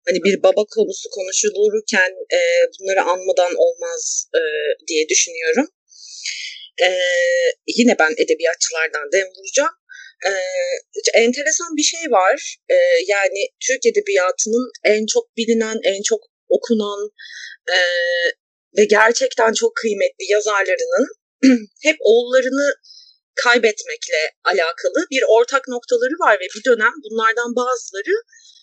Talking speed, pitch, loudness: 110 wpm, 310 Hz, -17 LUFS